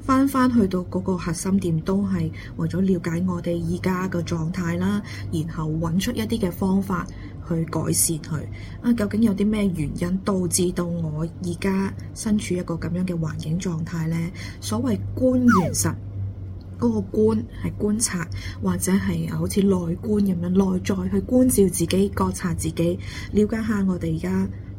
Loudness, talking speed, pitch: -23 LUFS, 245 characters per minute, 170 Hz